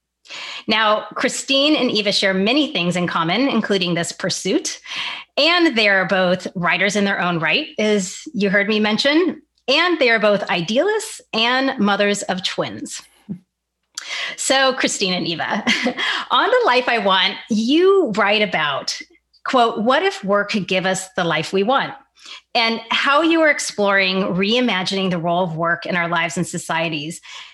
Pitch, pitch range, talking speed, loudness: 210 Hz, 190-265 Hz, 160 wpm, -18 LUFS